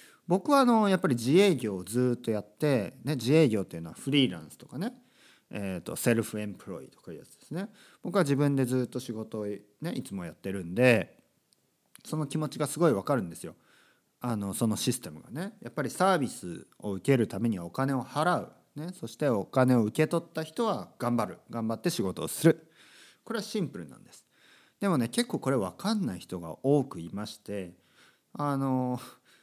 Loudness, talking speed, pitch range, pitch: -29 LUFS, 375 characters per minute, 110-160 Hz, 130 Hz